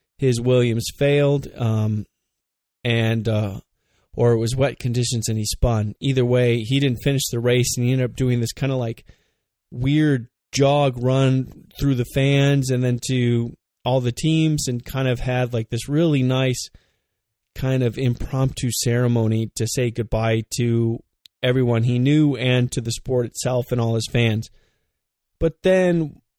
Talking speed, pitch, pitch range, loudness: 165 wpm, 125 Hz, 115-135 Hz, -21 LUFS